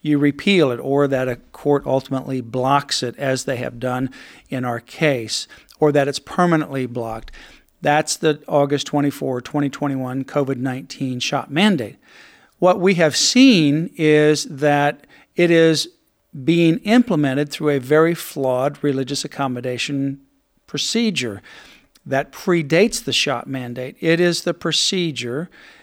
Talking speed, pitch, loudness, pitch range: 130 wpm, 145 Hz, -19 LUFS, 130-160 Hz